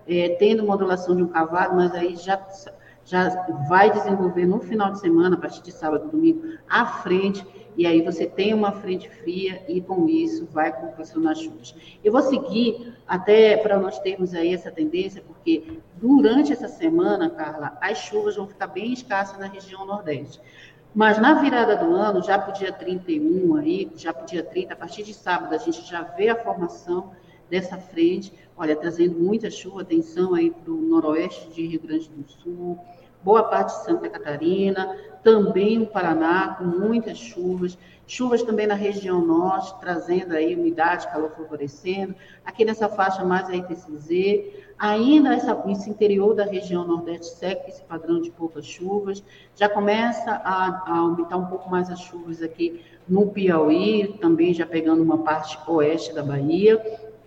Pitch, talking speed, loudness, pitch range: 185 Hz, 170 wpm, -22 LUFS, 170-215 Hz